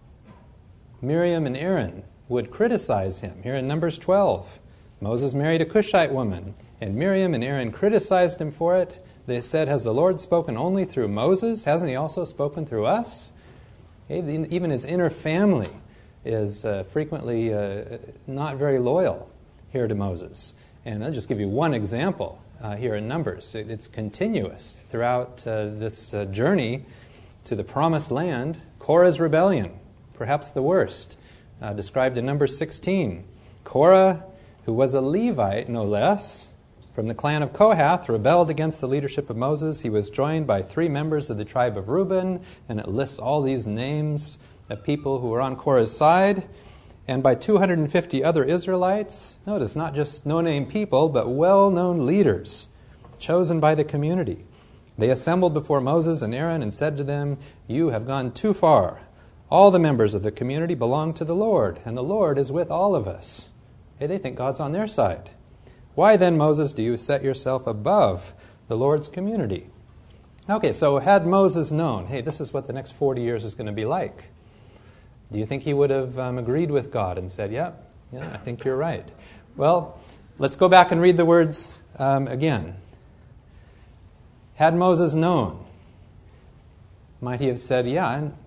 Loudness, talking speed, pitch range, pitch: -23 LUFS, 165 wpm, 115-165 Hz, 135 Hz